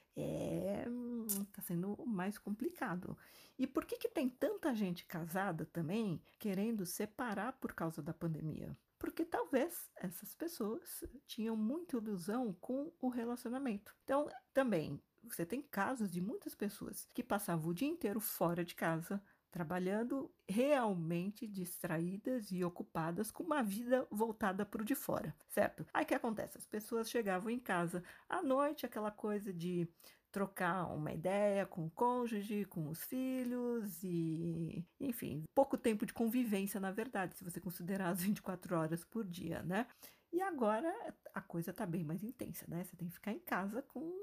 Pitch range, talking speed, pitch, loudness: 180-250 Hz, 155 wpm, 210 Hz, -40 LUFS